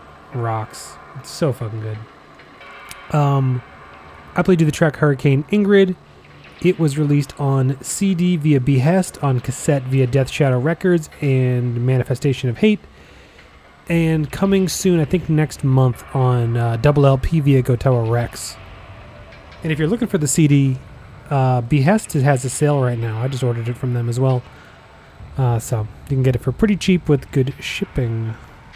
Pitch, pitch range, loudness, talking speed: 135 Hz, 120-155 Hz, -18 LUFS, 165 wpm